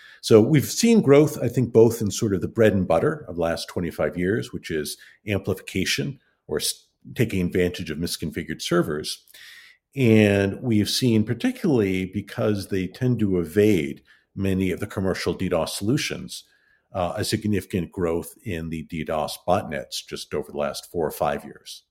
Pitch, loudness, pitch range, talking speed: 105 Hz, -23 LUFS, 90-115 Hz, 160 wpm